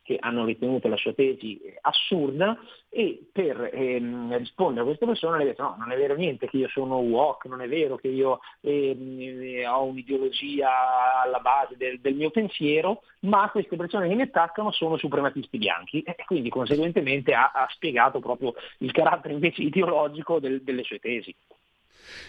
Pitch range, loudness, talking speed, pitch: 130-180 Hz, -26 LUFS, 170 wpm, 140 Hz